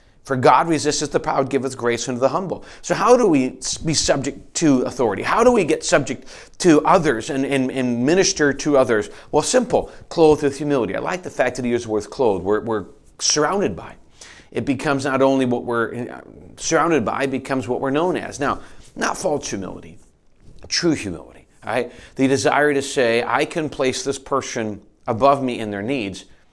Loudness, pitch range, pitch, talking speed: -19 LUFS, 115-140 Hz, 135 Hz, 190 wpm